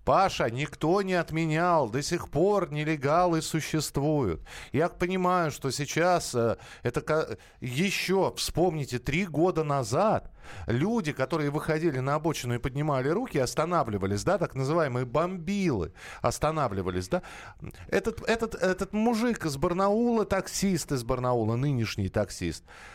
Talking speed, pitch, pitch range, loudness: 120 wpm, 155 Hz, 130-180 Hz, -28 LUFS